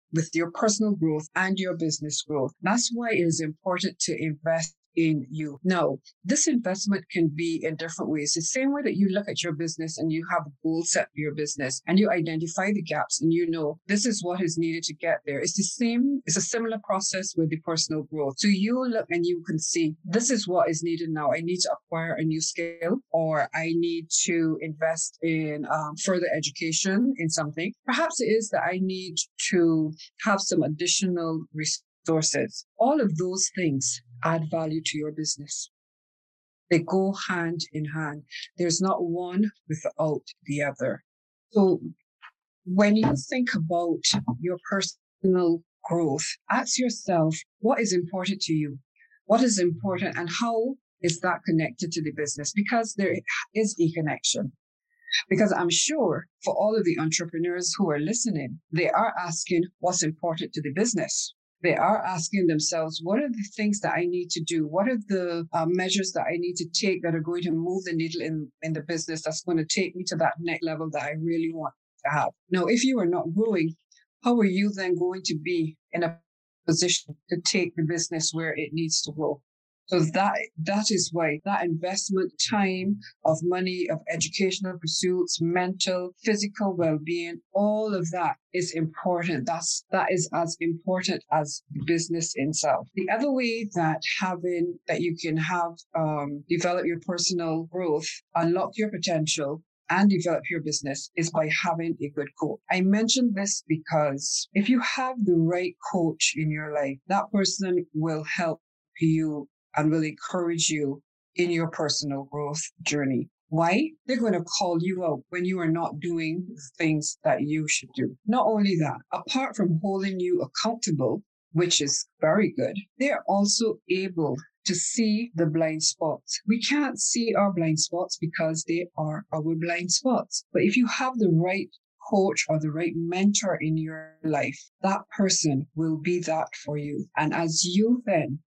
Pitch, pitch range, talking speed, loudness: 170 Hz, 160-195 Hz, 180 wpm, -26 LUFS